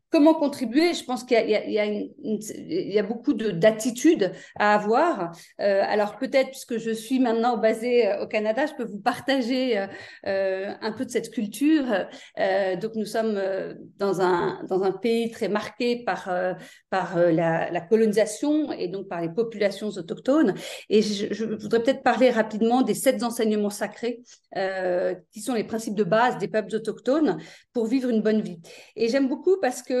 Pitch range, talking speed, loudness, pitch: 205-250 Hz, 185 wpm, -24 LUFS, 220 Hz